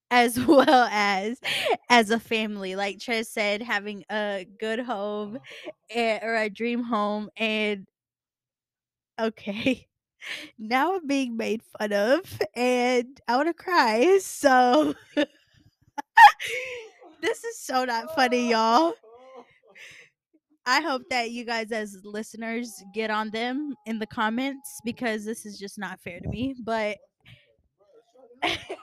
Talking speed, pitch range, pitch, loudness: 125 wpm, 210-265 Hz, 230 Hz, -24 LUFS